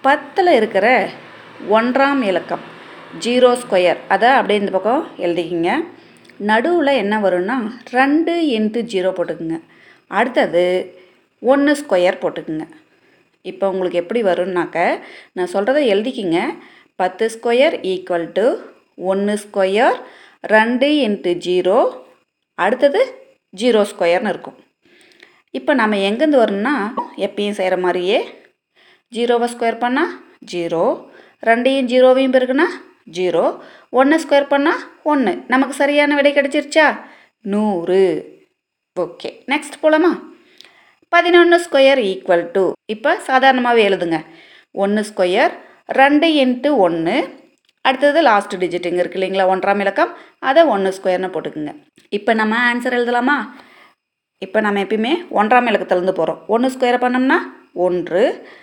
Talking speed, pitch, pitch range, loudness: 110 wpm, 240 Hz, 190-290 Hz, -16 LUFS